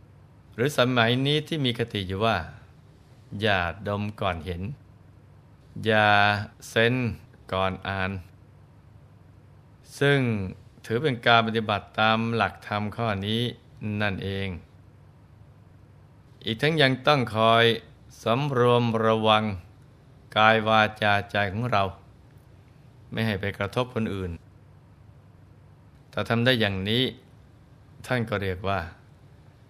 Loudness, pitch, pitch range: -24 LUFS, 110 Hz, 100-125 Hz